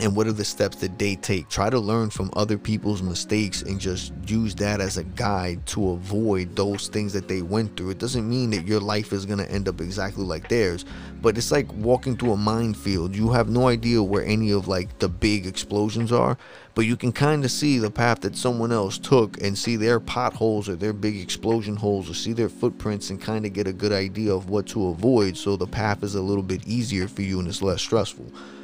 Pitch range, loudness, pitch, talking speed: 95-110 Hz, -24 LUFS, 105 Hz, 235 wpm